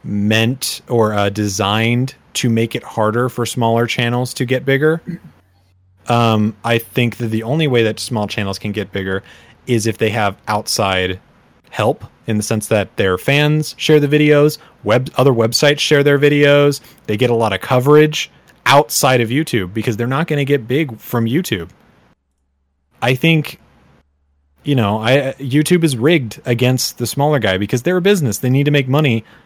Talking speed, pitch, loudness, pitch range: 175 wpm, 120 Hz, -15 LUFS, 105-145 Hz